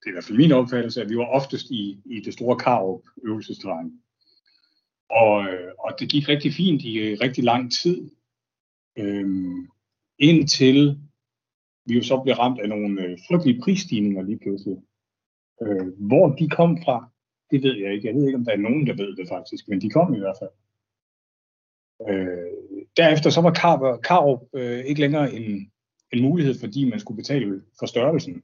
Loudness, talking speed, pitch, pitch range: -21 LUFS, 175 wpm, 120 Hz, 105-145 Hz